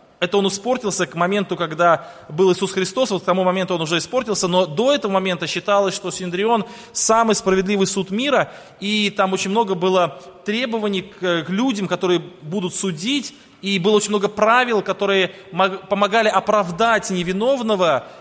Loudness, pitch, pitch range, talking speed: -19 LUFS, 195 Hz, 180-215 Hz, 155 wpm